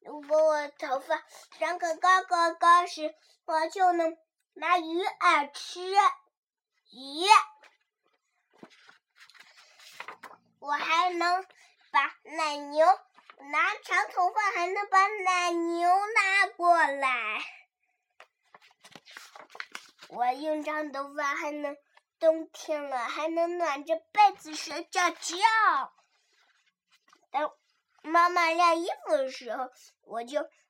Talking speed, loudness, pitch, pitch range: 125 characters per minute, -27 LUFS, 335 Hz, 305-370 Hz